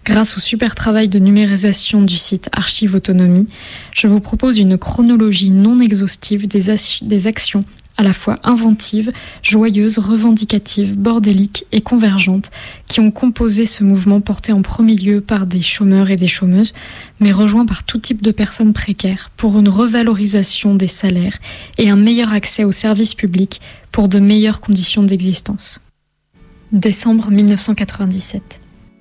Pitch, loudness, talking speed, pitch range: 210 Hz, -13 LUFS, 150 wpm, 195-220 Hz